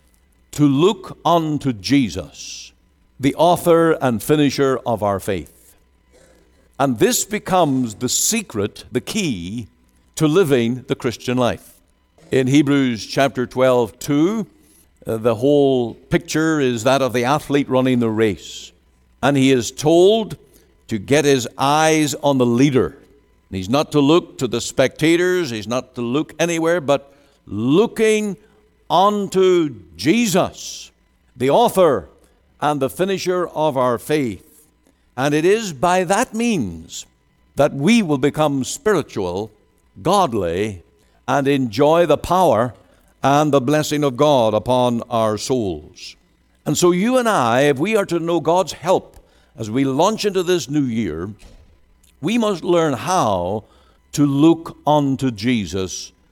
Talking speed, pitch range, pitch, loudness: 135 wpm, 115-165 Hz, 140 Hz, -18 LUFS